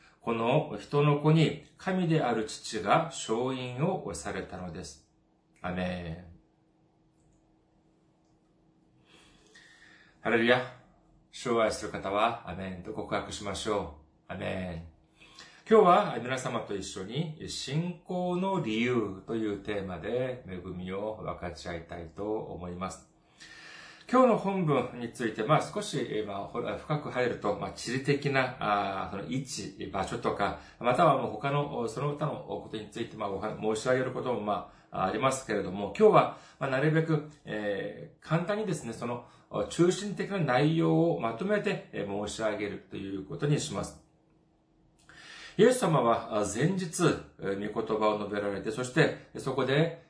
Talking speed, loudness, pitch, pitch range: 250 characters per minute, -30 LUFS, 115 Hz, 100-155 Hz